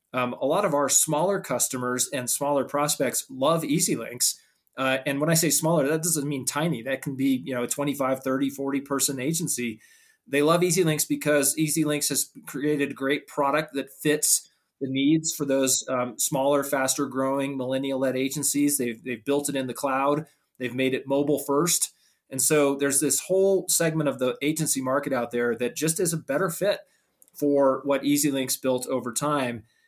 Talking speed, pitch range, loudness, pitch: 190 wpm, 130-150 Hz, -24 LUFS, 140 Hz